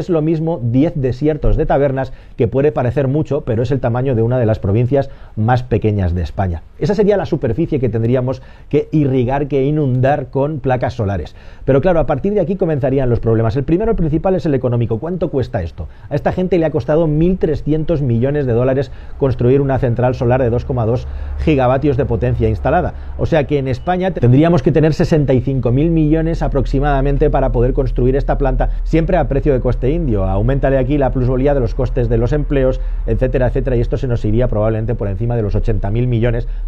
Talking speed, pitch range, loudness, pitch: 200 wpm, 120-150 Hz, -16 LUFS, 130 Hz